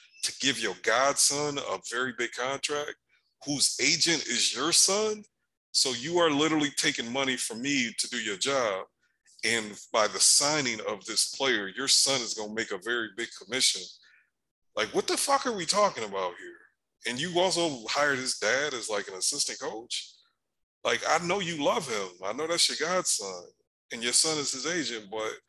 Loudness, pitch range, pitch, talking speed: -27 LUFS, 125-180 Hz, 145 Hz, 190 wpm